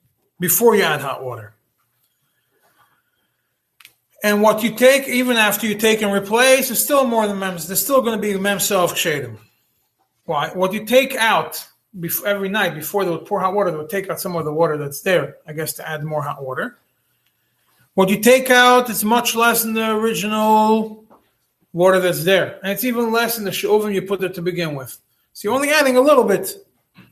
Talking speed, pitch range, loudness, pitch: 200 wpm, 170-230 Hz, -17 LUFS, 200 Hz